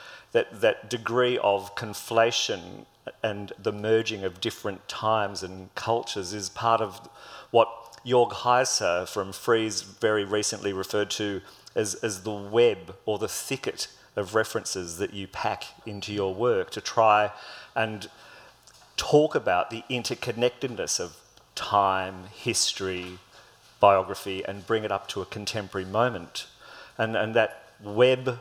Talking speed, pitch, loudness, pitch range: 130 wpm, 105 Hz, -27 LUFS, 100-115 Hz